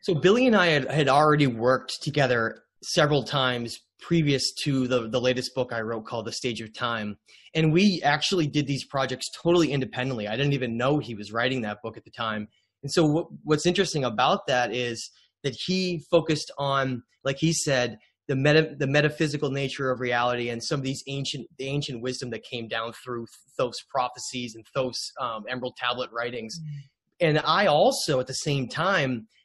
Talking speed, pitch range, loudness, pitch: 185 wpm, 120-150 Hz, -25 LUFS, 135 Hz